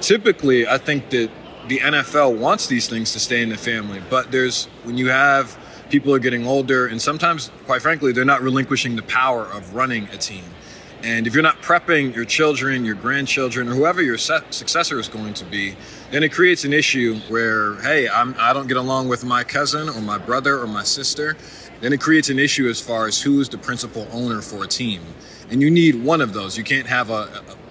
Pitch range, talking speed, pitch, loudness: 115-140 Hz, 225 wpm, 125 Hz, -19 LUFS